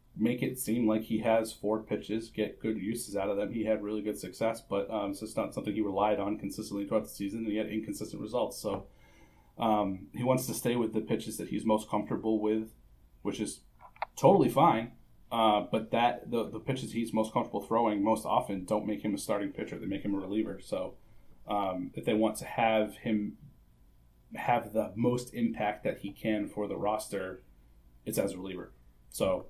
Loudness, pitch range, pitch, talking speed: -32 LUFS, 100-110 Hz, 105 Hz, 205 wpm